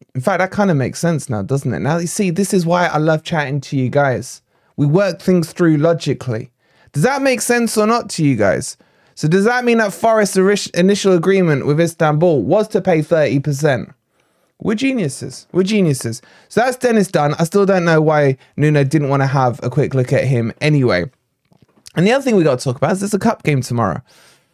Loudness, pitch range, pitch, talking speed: -16 LUFS, 135-195 Hz, 160 Hz, 225 wpm